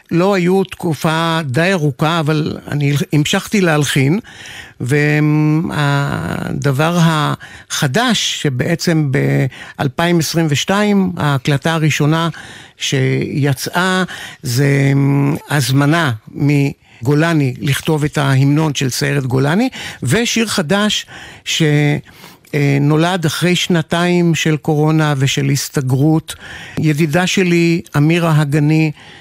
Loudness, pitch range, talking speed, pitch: -15 LUFS, 145-170 Hz, 80 wpm, 155 Hz